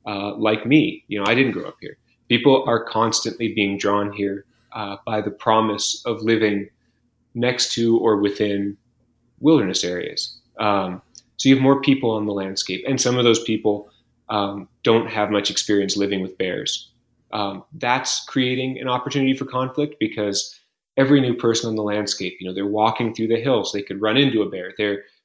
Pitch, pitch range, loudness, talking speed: 110 Hz, 100-125 Hz, -21 LUFS, 185 wpm